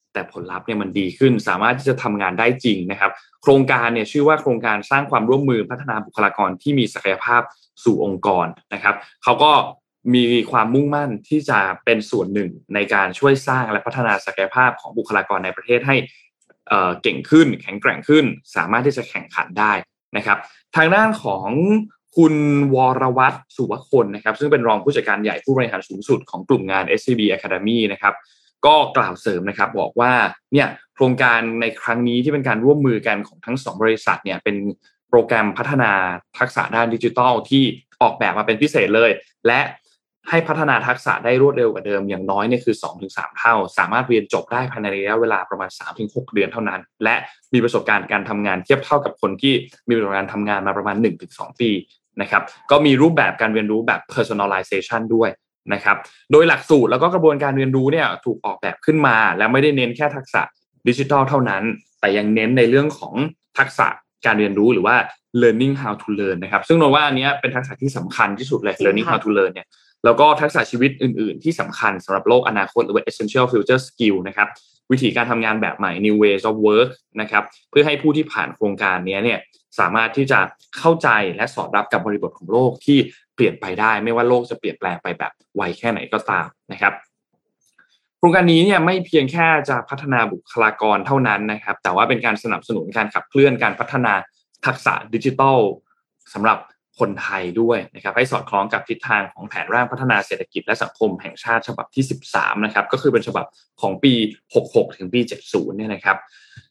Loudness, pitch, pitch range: -18 LUFS, 120 Hz, 105-140 Hz